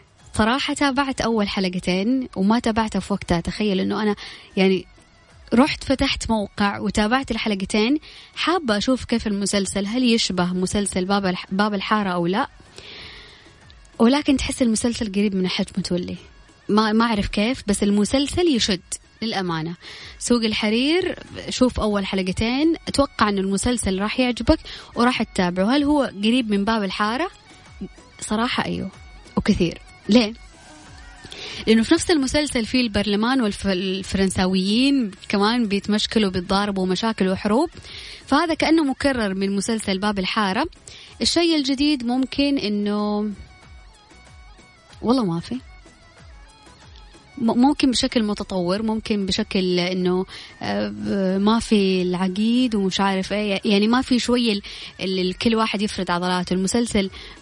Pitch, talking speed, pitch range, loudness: 215 Hz, 115 wpm, 195-245 Hz, -21 LUFS